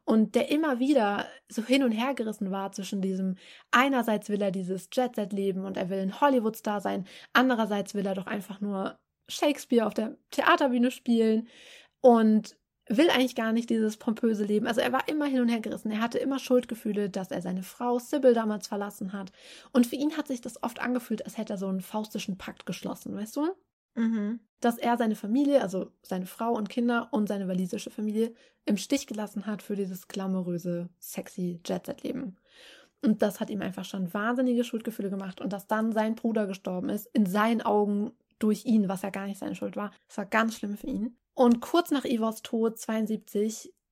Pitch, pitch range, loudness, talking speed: 220 Hz, 200-245 Hz, -29 LUFS, 200 wpm